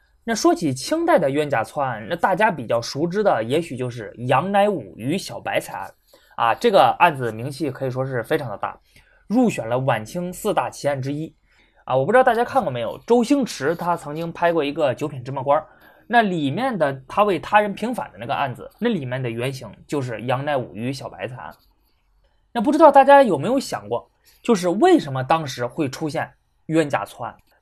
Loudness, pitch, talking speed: -21 LUFS, 160 Hz, 300 characters per minute